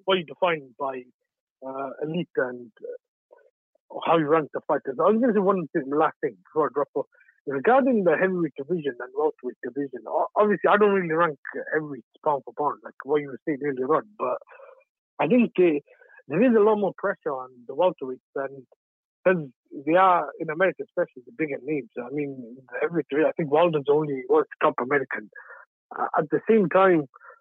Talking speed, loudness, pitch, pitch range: 185 wpm, -24 LUFS, 170 Hz, 140-210 Hz